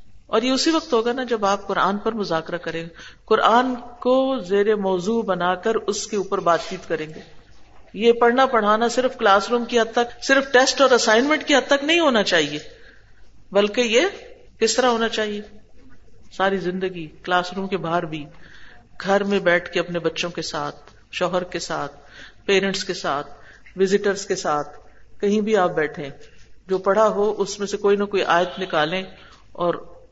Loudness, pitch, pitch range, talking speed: -20 LUFS, 195 Hz, 170-230 Hz, 180 wpm